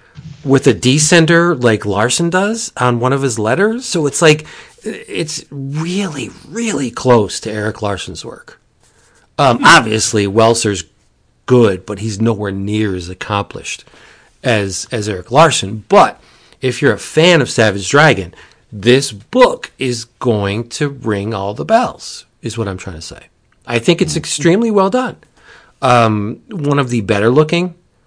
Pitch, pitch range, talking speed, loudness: 120 Hz, 105-155 Hz, 150 wpm, -14 LUFS